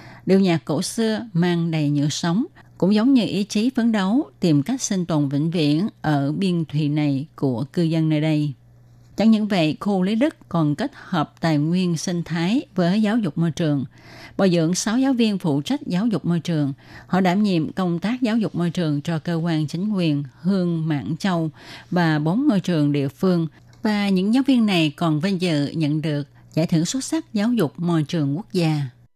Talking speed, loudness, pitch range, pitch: 210 wpm, -21 LUFS, 150-200 Hz, 170 Hz